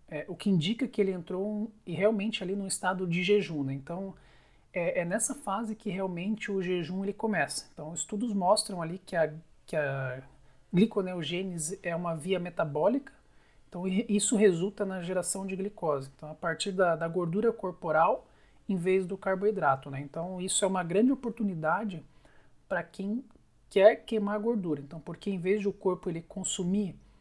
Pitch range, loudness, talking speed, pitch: 170-210 Hz, -30 LUFS, 175 wpm, 190 Hz